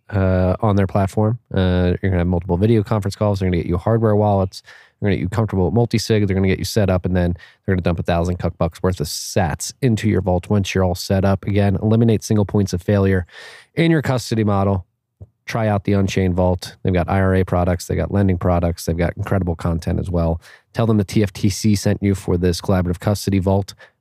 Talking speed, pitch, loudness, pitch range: 225 wpm, 95 Hz, -19 LUFS, 90-105 Hz